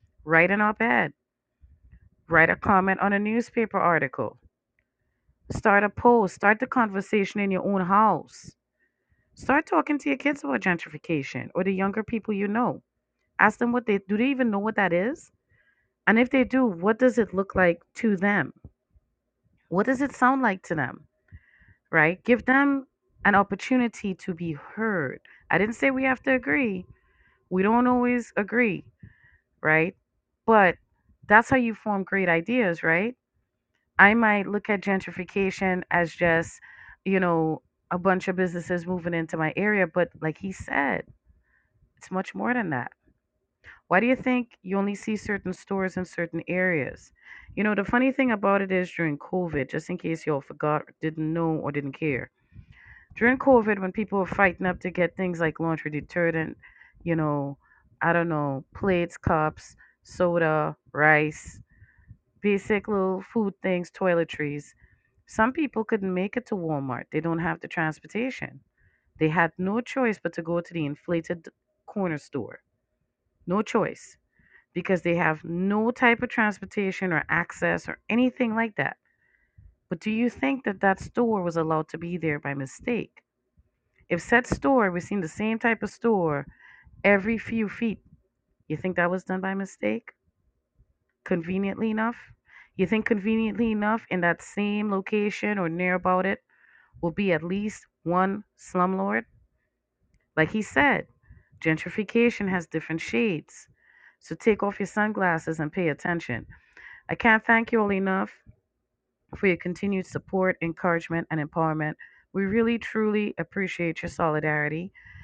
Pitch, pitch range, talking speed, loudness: 190 Hz, 165-220 Hz, 155 wpm, -25 LUFS